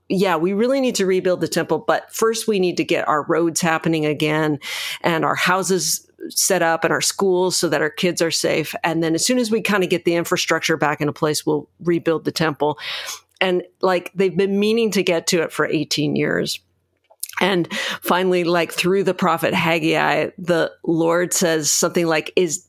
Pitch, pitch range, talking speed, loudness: 175 Hz, 160-185 Hz, 200 wpm, -19 LUFS